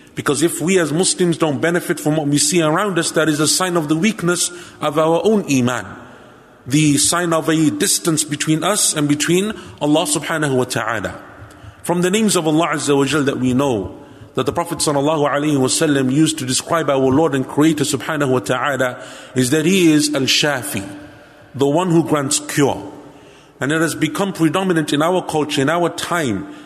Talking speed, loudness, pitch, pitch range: 195 wpm, -17 LUFS, 155 Hz, 140-165 Hz